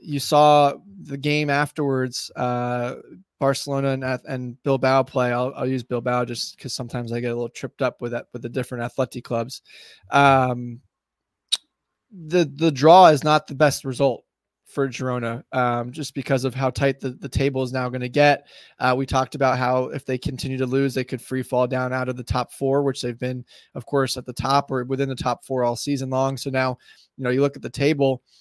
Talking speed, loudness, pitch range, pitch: 215 wpm, -22 LUFS, 125-140 Hz, 130 Hz